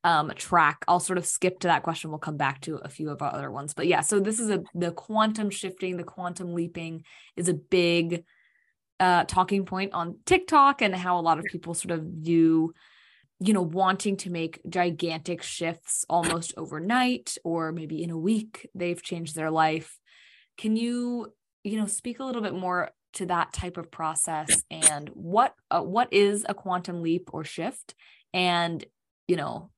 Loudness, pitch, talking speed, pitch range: -27 LUFS, 175 Hz, 185 wpm, 165-195 Hz